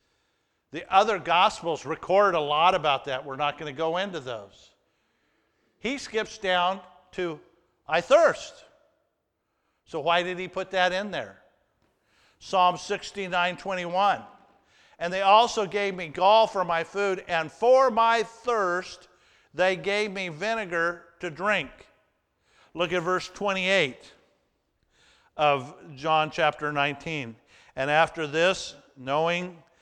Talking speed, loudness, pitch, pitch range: 125 wpm, -25 LUFS, 180 Hz, 165-200 Hz